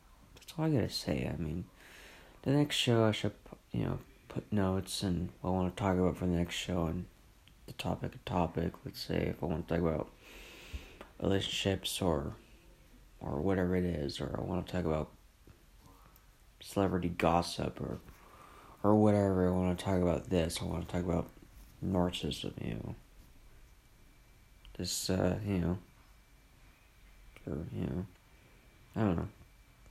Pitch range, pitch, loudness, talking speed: 85-95 Hz, 90 Hz, -34 LUFS, 150 wpm